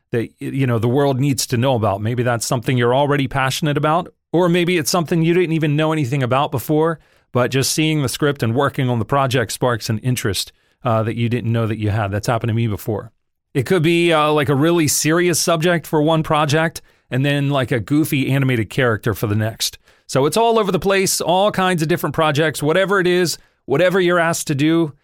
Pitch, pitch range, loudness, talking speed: 145 Hz, 120-165 Hz, -18 LUFS, 225 wpm